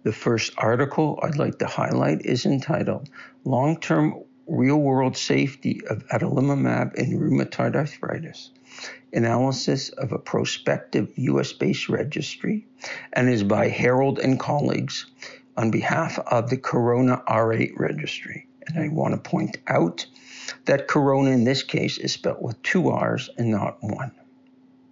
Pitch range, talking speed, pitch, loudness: 120-155 Hz, 130 wpm, 130 Hz, -23 LUFS